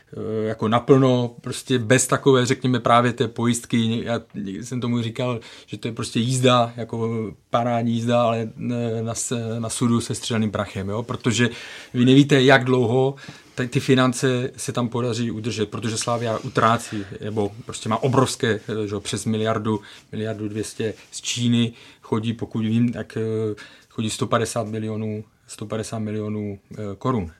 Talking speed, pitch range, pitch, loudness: 140 wpm, 110-125 Hz, 115 Hz, -22 LUFS